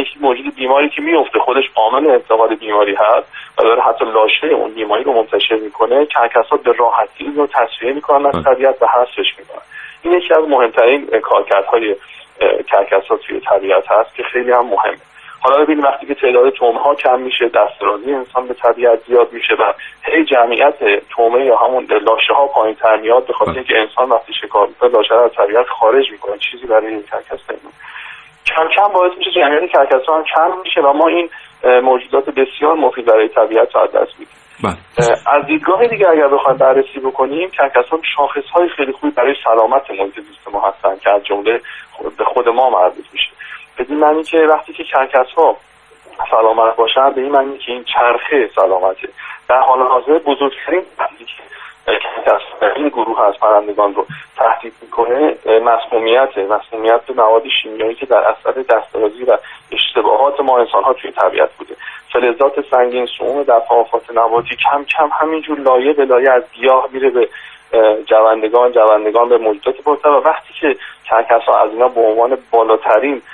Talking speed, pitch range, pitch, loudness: 165 wpm, 120-185 Hz, 140 Hz, -13 LUFS